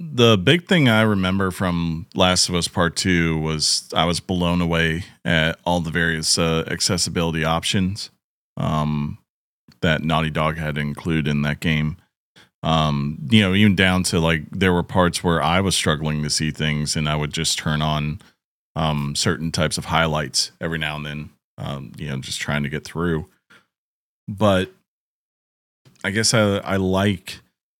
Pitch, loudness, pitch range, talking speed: 80 Hz, -20 LUFS, 75-95 Hz, 170 wpm